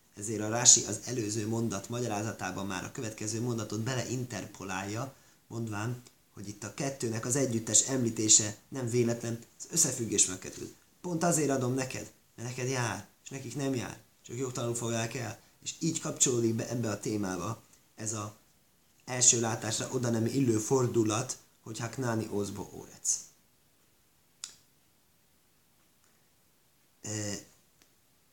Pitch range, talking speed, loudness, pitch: 105-125 Hz, 130 wpm, -30 LUFS, 115 Hz